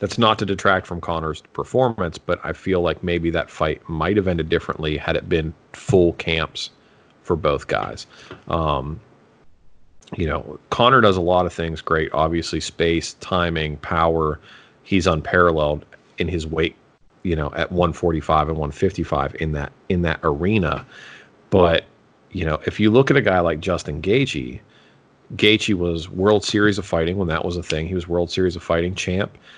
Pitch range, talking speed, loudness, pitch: 80-95 Hz, 175 wpm, -21 LUFS, 85 Hz